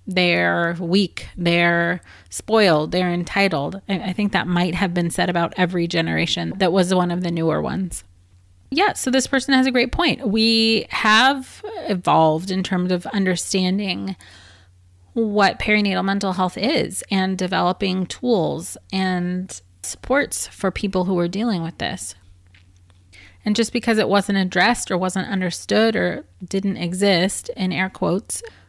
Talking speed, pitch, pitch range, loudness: 145 wpm, 185 Hz, 170-200 Hz, -20 LUFS